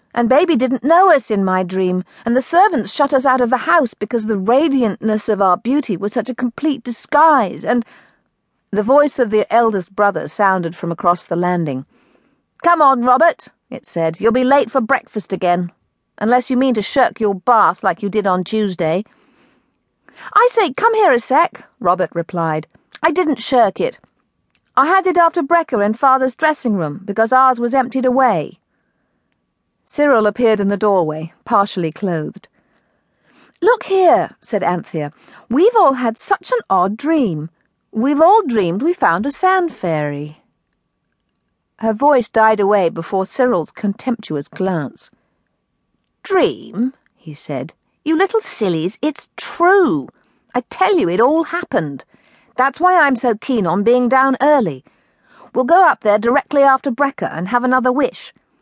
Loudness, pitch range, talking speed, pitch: -16 LUFS, 195-295 Hz, 160 wpm, 245 Hz